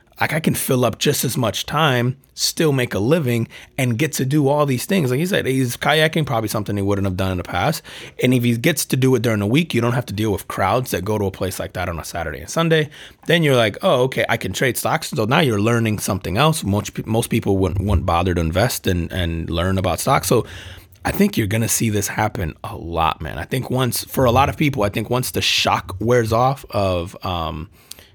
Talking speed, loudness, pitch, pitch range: 255 wpm, -19 LUFS, 115 Hz, 95-130 Hz